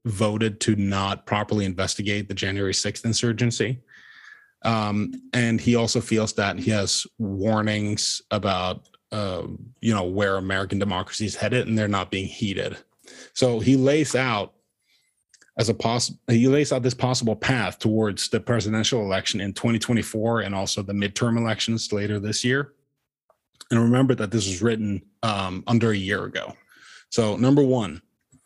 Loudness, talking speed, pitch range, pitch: -23 LUFS, 160 wpm, 100-120 Hz, 110 Hz